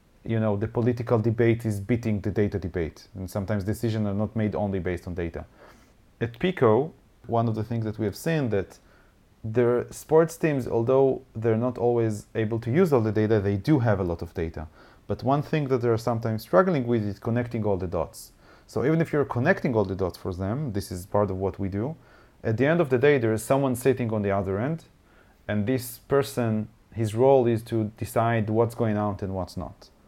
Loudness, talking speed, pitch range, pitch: -26 LUFS, 220 wpm, 100-120 Hz, 110 Hz